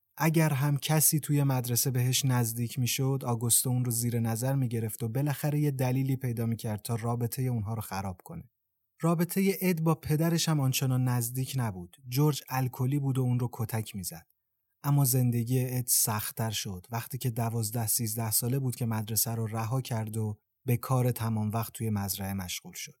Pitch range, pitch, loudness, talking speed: 115-135 Hz, 125 Hz, -29 LUFS, 175 wpm